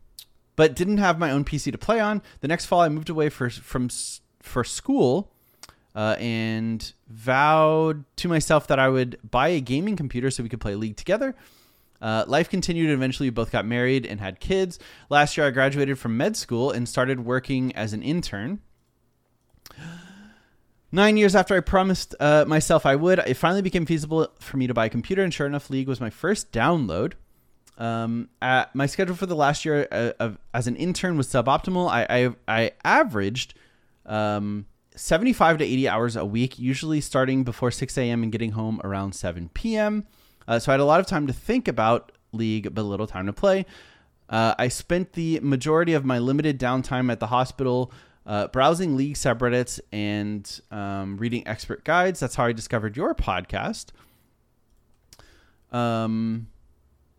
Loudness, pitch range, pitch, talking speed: -24 LUFS, 115-160 Hz, 130 Hz, 180 wpm